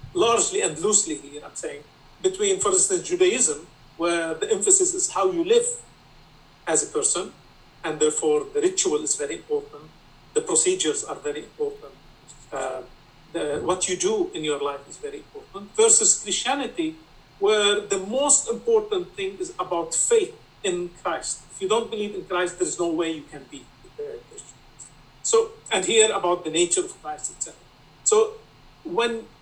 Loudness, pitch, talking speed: -23 LUFS, 370 Hz, 165 wpm